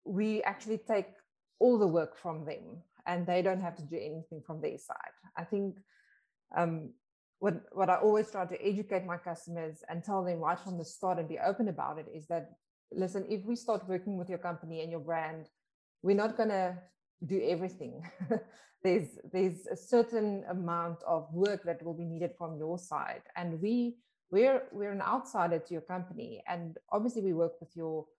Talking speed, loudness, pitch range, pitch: 190 wpm, -34 LUFS, 170-205 Hz, 180 Hz